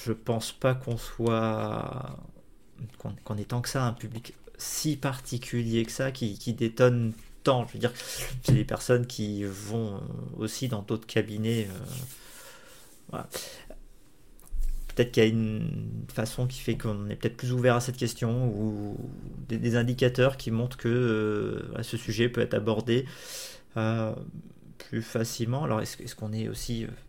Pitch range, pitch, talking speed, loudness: 110-125 Hz, 120 Hz, 160 wpm, -30 LUFS